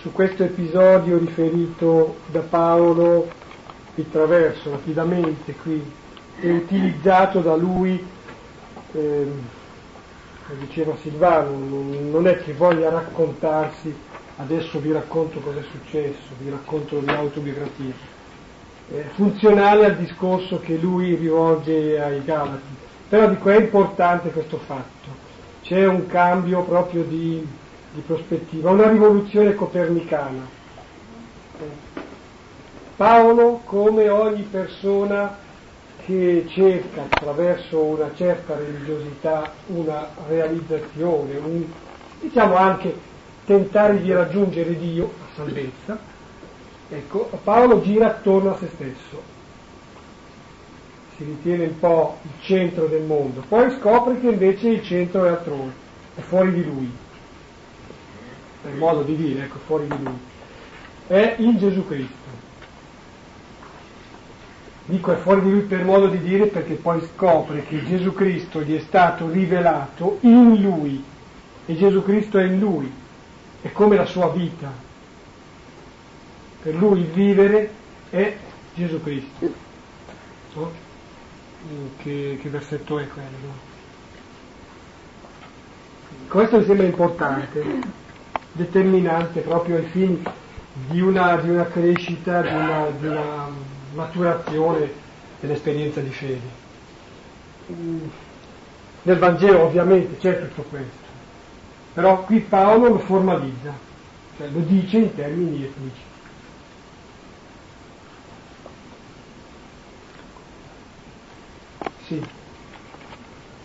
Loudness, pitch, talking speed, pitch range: -19 LUFS, 165 Hz, 105 wpm, 145-185 Hz